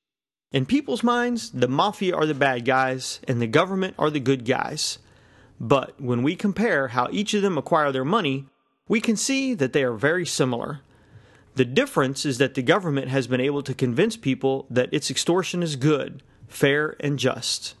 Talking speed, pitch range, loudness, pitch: 185 wpm, 130-165 Hz, -23 LUFS, 140 Hz